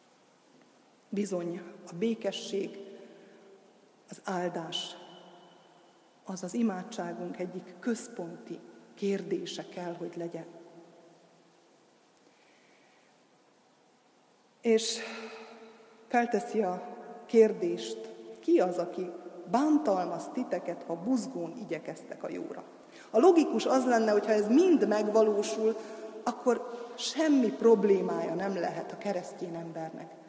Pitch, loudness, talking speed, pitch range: 205 Hz, -30 LUFS, 90 wpm, 175-230 Hz